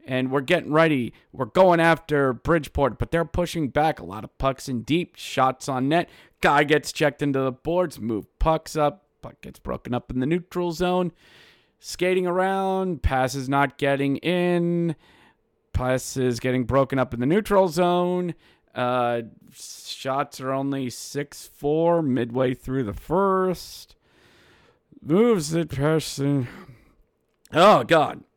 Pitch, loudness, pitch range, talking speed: 145 Hz, -23 LUFS, 130-170 Hz, 140 wpm